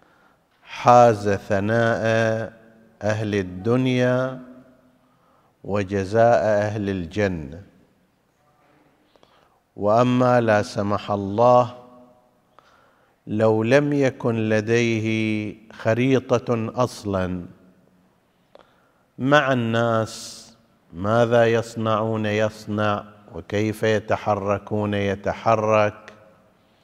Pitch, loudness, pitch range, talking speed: 110 Hz, -21 LUFS, 105-120 Hz, 55 wpm